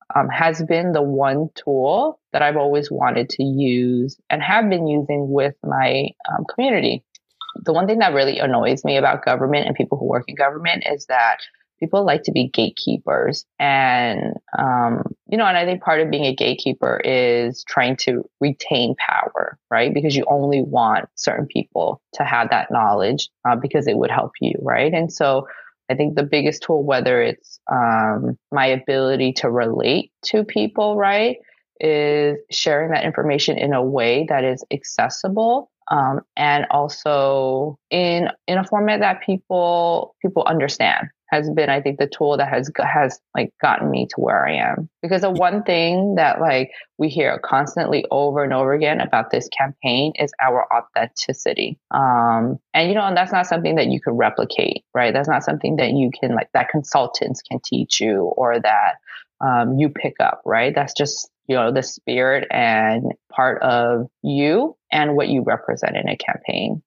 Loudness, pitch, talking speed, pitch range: -19 LUFS, 145 Hz, 180 wpm, 135-170 Hz